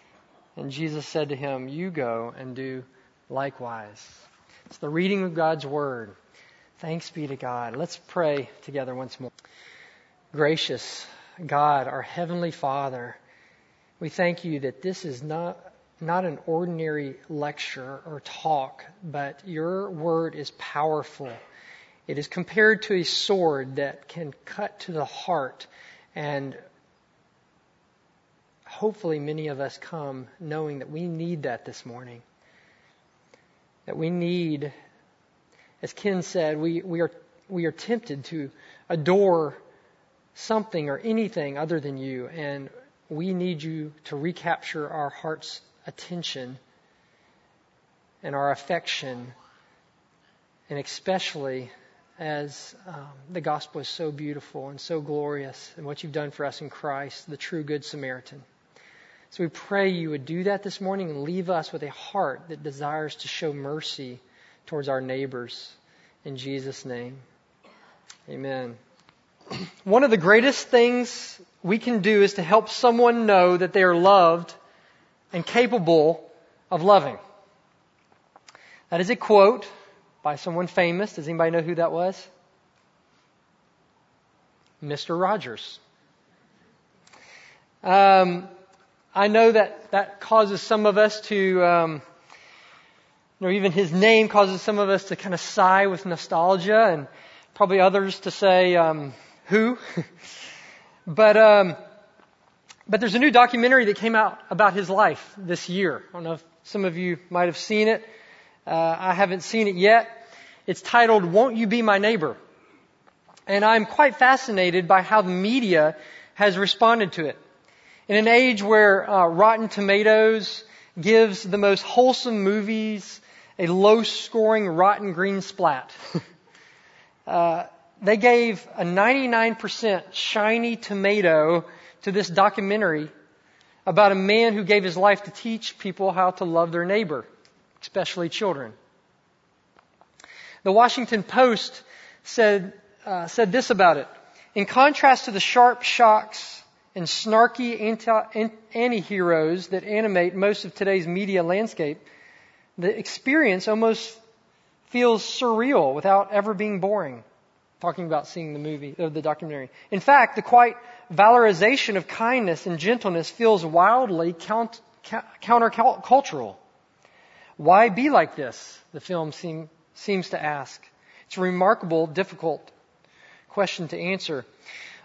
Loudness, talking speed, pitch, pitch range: -22 LUFS, 135 wpm, 185 Hz, 155-210 Hz